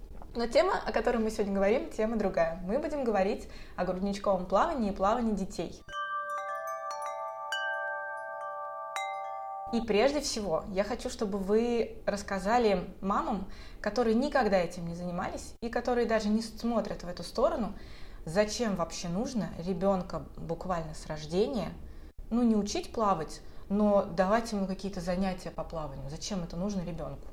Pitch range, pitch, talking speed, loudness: 170-220 Hz, 195 Hz, 135 wpm, -32 LUFS